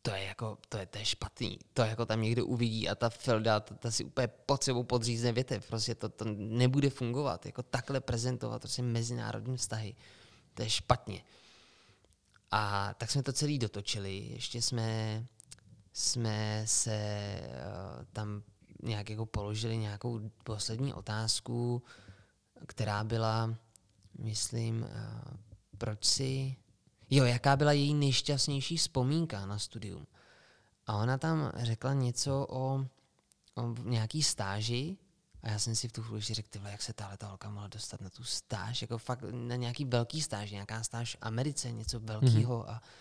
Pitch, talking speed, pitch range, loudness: 115 Hz, 155 wpm, 110-125 Hz, -34 LUFS